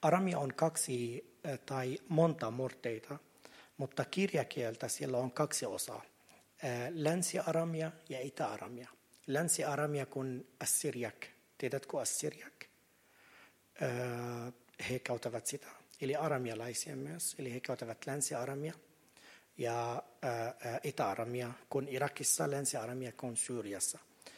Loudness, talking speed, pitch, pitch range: -38 LUFS, 90 wpm, 130 Hz, 120-150 Hz